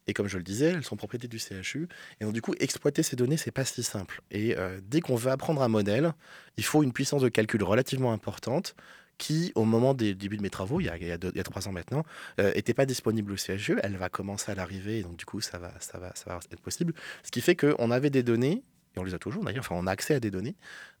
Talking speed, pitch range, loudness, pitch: 290 wpm, 100-130 Hz, -30 LUFS, 110 Hz